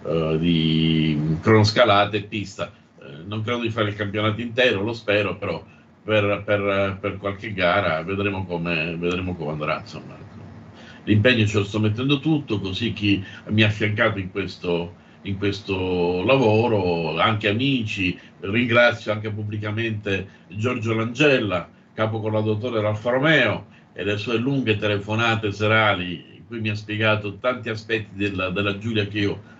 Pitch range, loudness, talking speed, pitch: 95-110 Hz, -22 LUFS, 150 wpm, 105 Hz